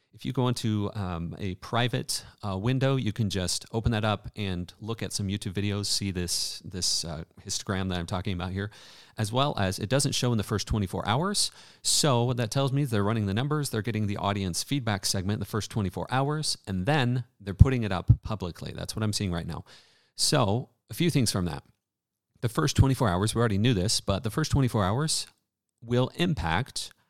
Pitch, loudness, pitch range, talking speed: 105 Hz, -28 LUFS, 100-125 Hz, 215 wpm